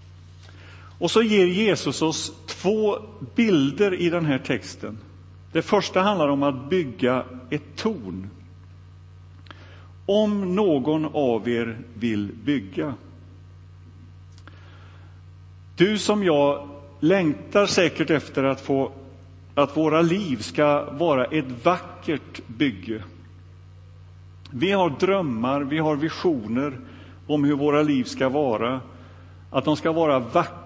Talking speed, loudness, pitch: 115 wpm, -23 LUFS, 130 Hz